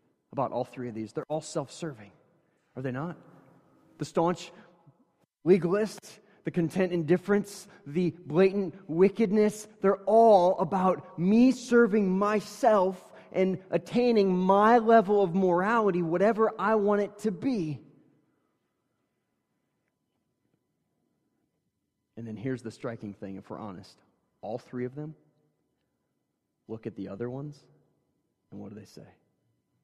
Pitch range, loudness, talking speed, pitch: 140-205 Hz, -26 LUFS, 125 wpm, 180 Hz